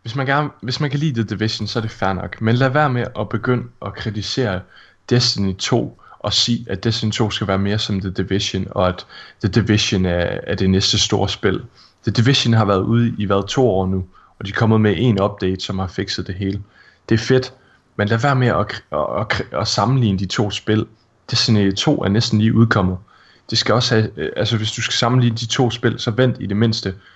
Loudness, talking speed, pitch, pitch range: -18 LUFS, 235 wpm, 110 Hz, 100-120 Hz